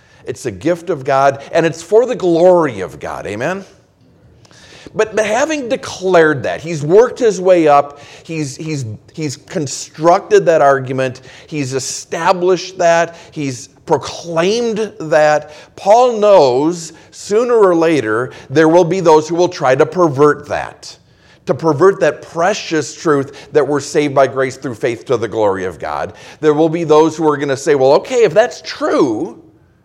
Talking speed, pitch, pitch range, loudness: 165 wpm, 160 Hz, 145-185 Hz, -14 LUFS